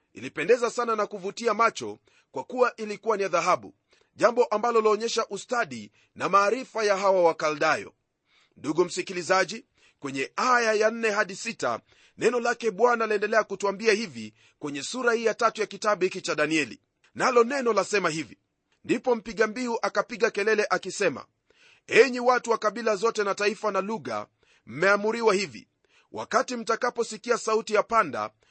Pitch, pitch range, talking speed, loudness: 220 Hz, 195-230 Hz, 145 wpm, -25 LUFS